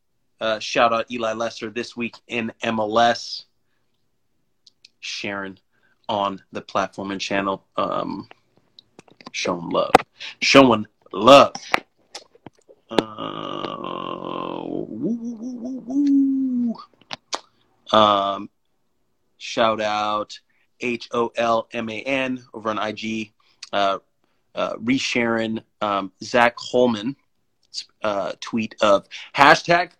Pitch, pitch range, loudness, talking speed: 115 Hz, 110-150 Hz, -21 LUFS, 95 wpm